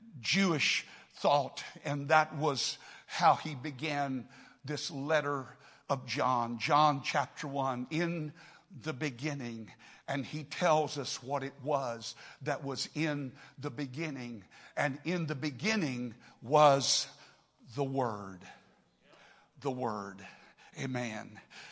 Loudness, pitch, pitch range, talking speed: -33 LUFS, 140 Hz, 130-150 Hz, 110 wpm